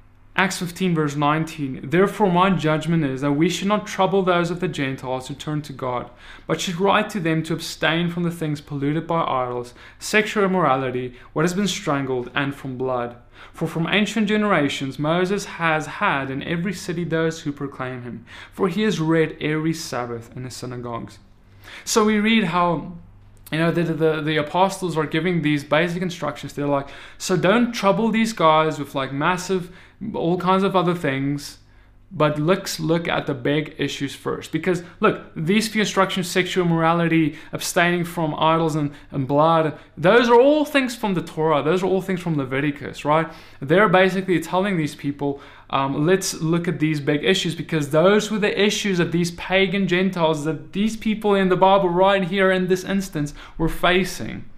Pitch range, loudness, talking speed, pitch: 145-185 Hz, -21 LUFS, 180 wpm, 165 Hz